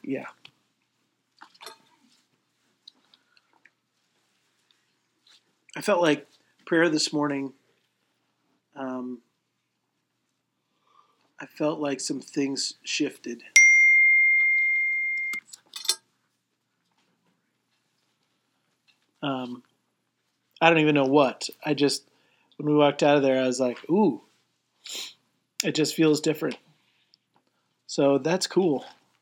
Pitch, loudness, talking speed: 150 Hz, -22 LUFS, 80 wpm